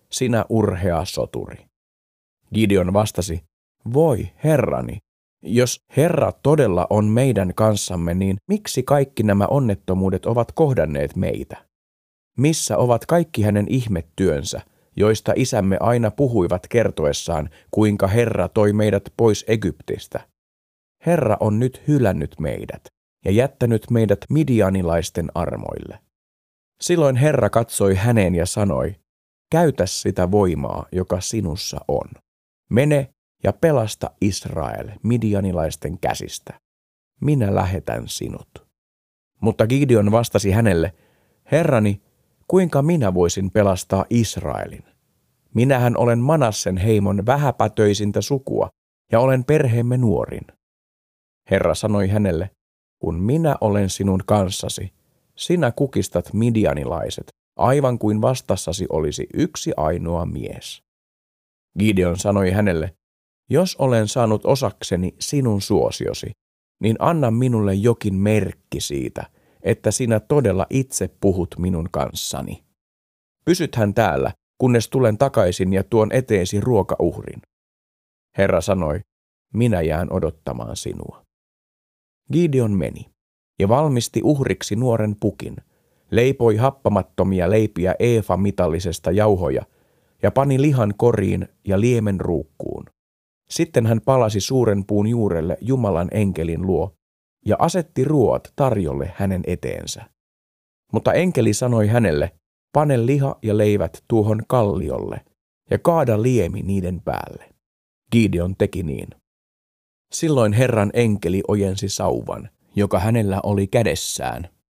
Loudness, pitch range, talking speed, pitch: -20 LUFS, 90-120 Hz, 105 wpm, 105 Hz